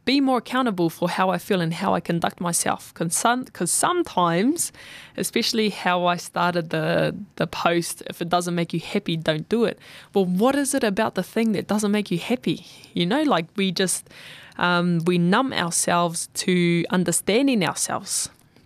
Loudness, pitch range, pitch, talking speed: -23 LUFS, 170-220 Hz, 180 Hz, 175 wpm